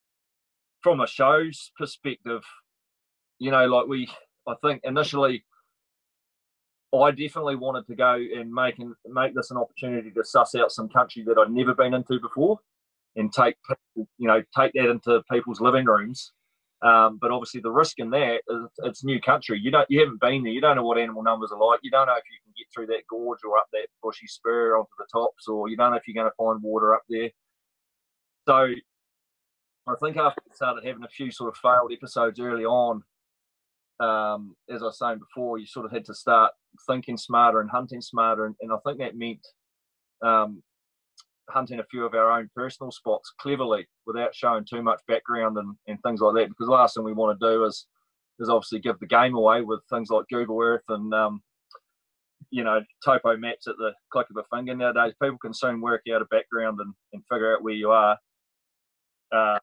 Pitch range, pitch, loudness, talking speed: 110-125 Hz, 120 Hz, -24 LUFS, 205 wpm